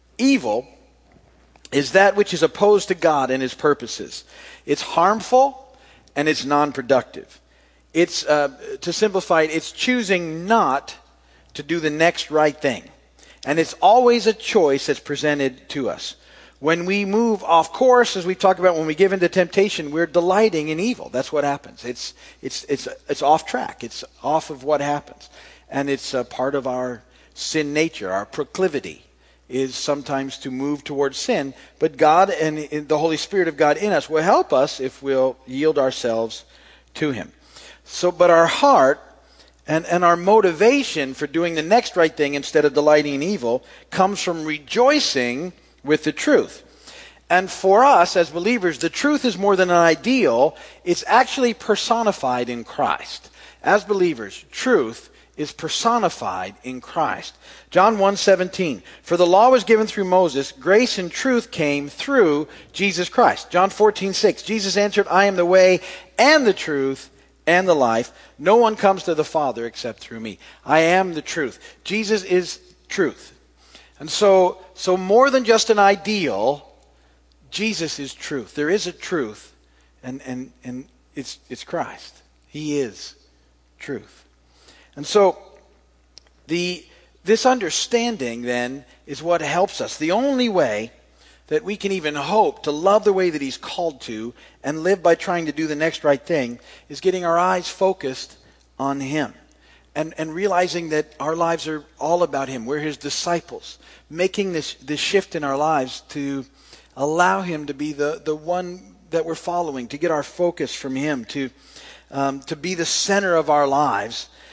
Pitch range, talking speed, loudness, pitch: 140-190 Hz, 165 wpm, -20 LUFS, 160 Hz